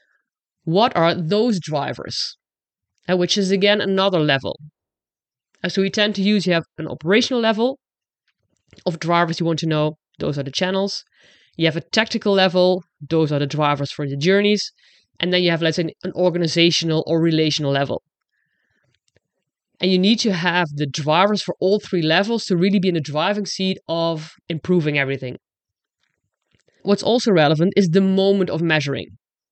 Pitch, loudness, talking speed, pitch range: 175 Hz, -19 LUFS, 165 wpm, 155-195 Hz